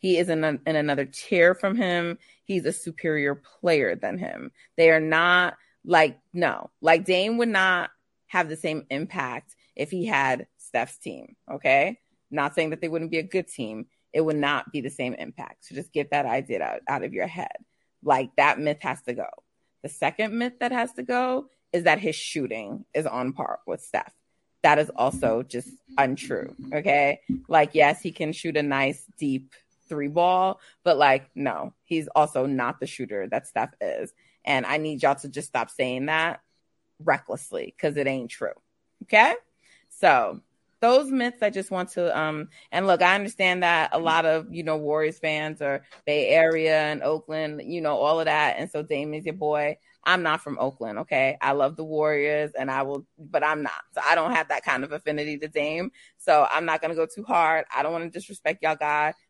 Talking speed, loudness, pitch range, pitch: 200 wpm, -24 LUFS, 145-175 Hz, 155 Hz